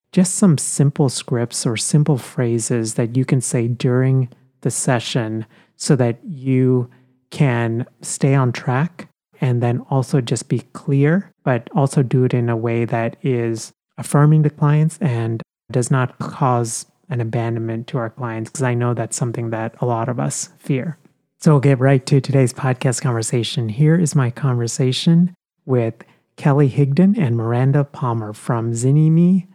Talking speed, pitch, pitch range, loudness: 160 wpm, 130 Hz, 120-145 Hz, -18 LUFS